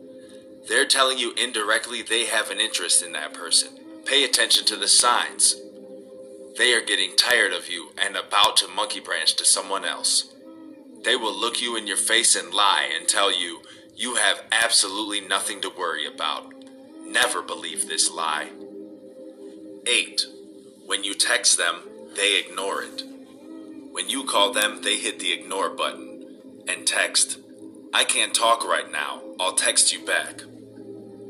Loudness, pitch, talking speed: -21 LUFS, 130 Hz, 155 wpm